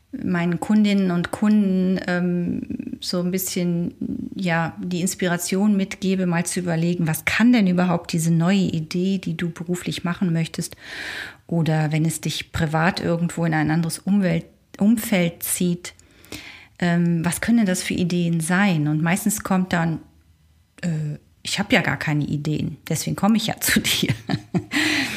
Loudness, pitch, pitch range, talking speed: -22 LUFS, 175 Hz, 165-195 Hz, 155 wpm